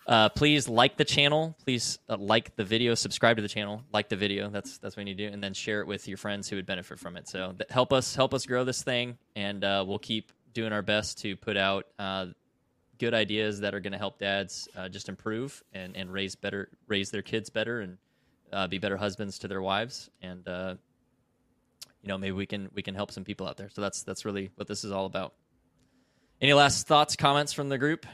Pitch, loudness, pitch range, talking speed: 105 Hz, -29 LUFS, 100-120 Hz, 240 wpm